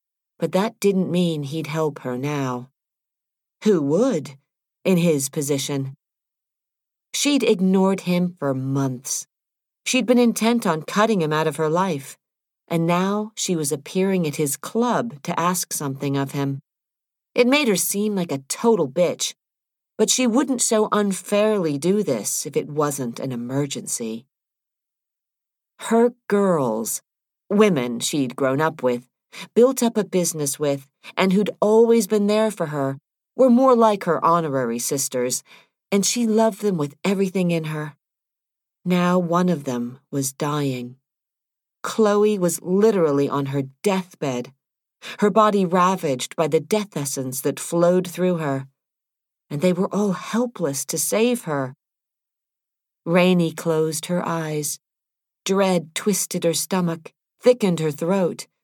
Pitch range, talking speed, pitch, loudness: 145-205 Hz, 140 wpm, 170 Hz, -21 LUFS